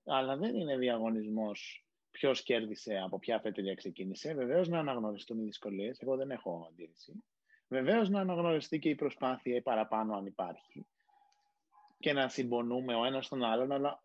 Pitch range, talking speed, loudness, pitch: 110-165 Hz, 160 wpm, -35 LUFS, 130 Hz